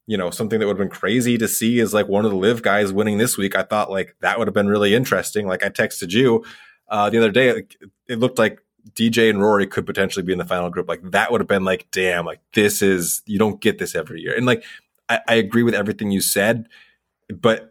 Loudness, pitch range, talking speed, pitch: -19 LUFS, 100-115 Hz, 260 wpm, 105 Hz